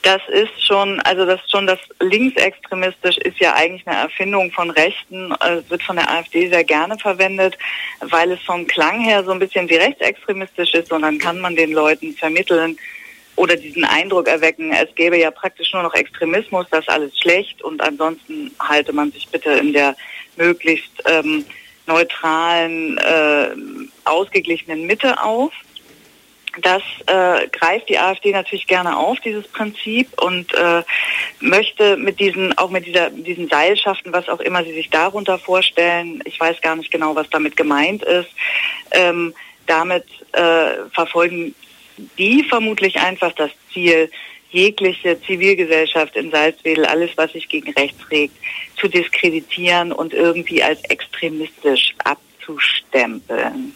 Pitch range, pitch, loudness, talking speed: 160-195 Hz, 175 Hz, -16 LUFS, 150 wpm